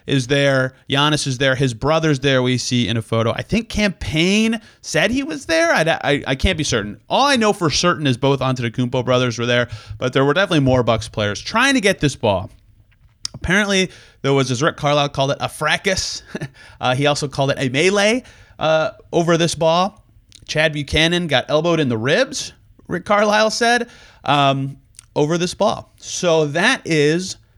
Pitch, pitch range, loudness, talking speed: 145 Hz, 125-175 Hz, -18 LUFS, 190 wpm